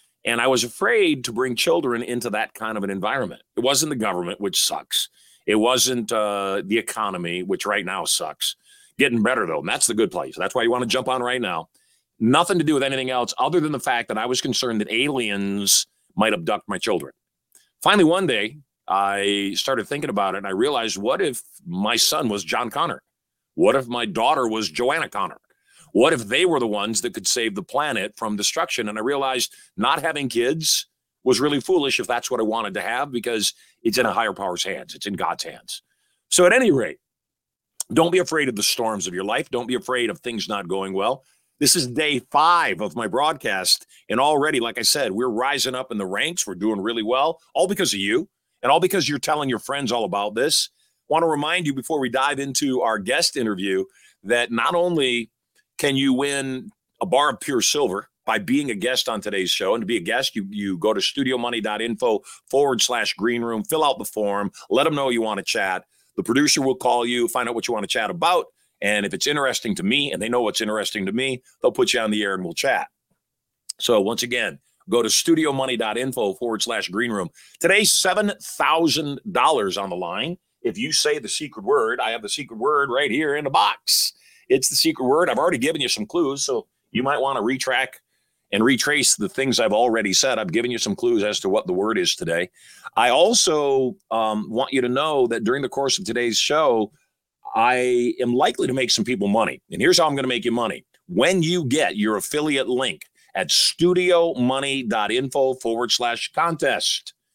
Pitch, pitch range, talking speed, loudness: 130 Hz, 115-165 Hz, 215 wpm, -21 LUFS